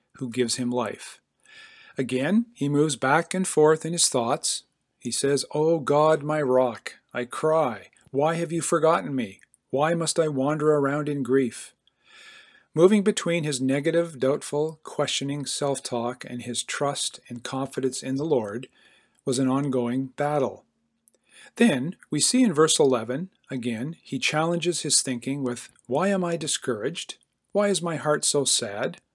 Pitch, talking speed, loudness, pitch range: 150 Hz, 155 wpm, -24 LUFS, 130-170 Hz